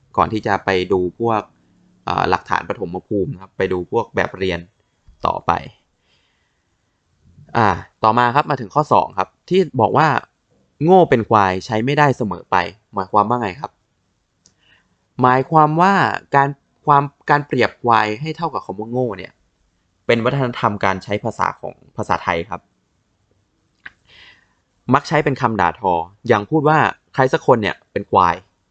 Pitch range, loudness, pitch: 95-135 Hz, -18 LUFS, 110 Hz